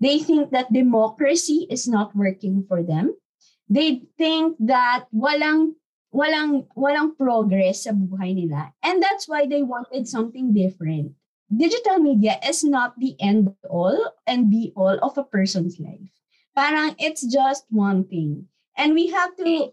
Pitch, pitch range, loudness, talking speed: 250 Hz, 195-300 Hz, -21 LUFS, 150 wpm